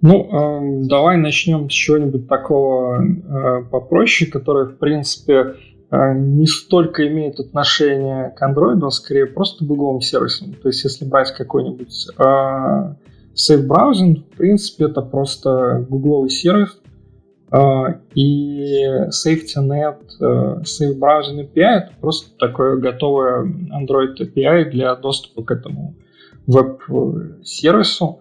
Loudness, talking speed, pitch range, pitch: -16 LUFS, 120 wpm, 130-155 Hz, 140 Hz